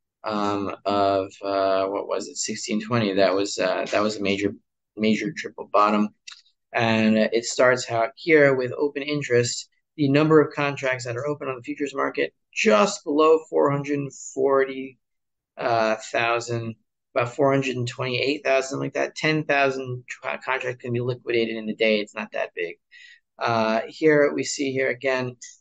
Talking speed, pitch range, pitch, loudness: 145 wpm, 110-140 Hz, 125 Hz, -23 LUFS